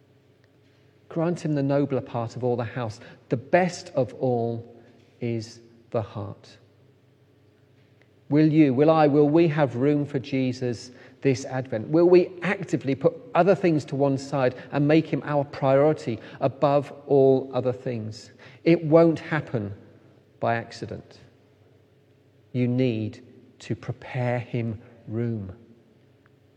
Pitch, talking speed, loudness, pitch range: 135 Hz, 130 wpm, -24 LUFS, 120-145 Hz